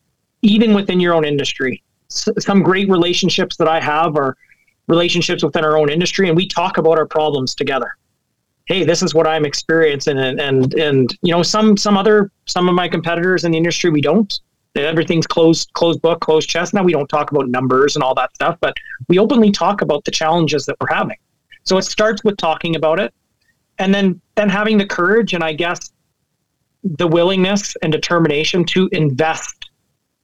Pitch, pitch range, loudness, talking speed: 170 Hz, 155-190 Hz, -15 LUFS, 190 wpm